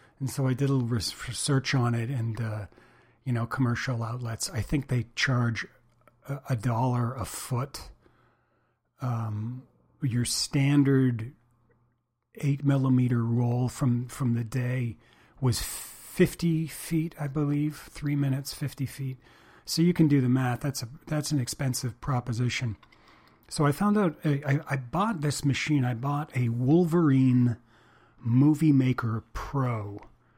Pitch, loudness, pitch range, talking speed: 130 Hz, -28 LUFS, 120-145 Hz, 140 wpm